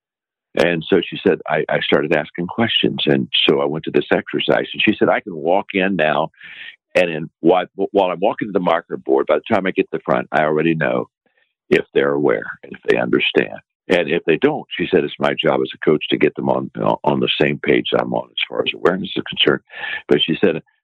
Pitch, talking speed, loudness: 90 Hz, 240 wpm, -18 LUFS